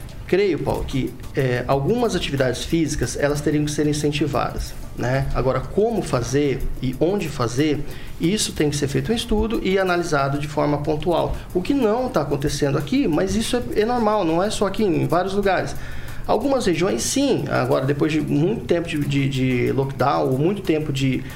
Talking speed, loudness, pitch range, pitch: 180 wpm, -21 LUFS, 140-190 Hz, 150 Hz